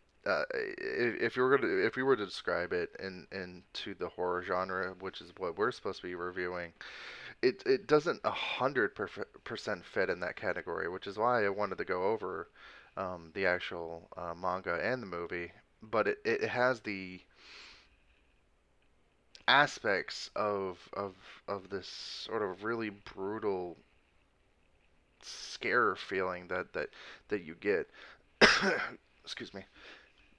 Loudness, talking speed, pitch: -34 LUFS, 145 wpm, 100 Hz